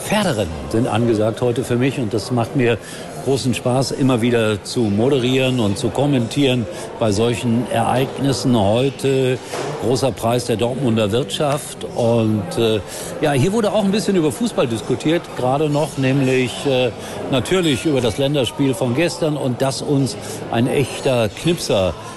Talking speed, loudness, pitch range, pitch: 150 wpm, -18 LUFS, 115-135 Hz, 125 Hz